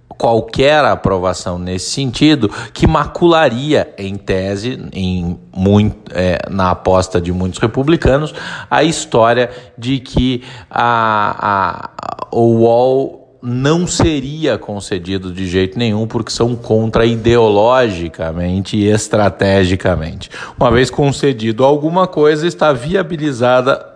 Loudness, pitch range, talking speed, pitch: -14 LUFS, 95-135 Hz, 110 wpm, 115 Hz